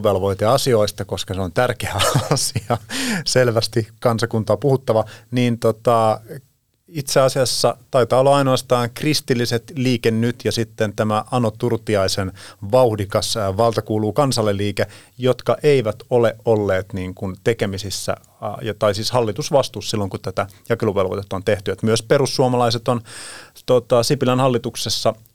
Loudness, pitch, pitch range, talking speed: -19 LUFS, 115 Hz, 105-125 Hz, 120 wpm